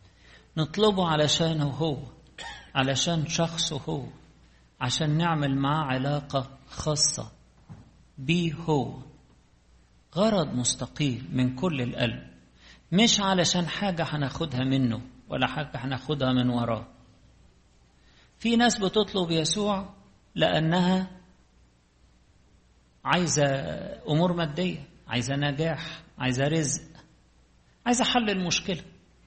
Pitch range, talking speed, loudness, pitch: 125-170 Hz, 90 wpm, -26 LUFS, 150 Hz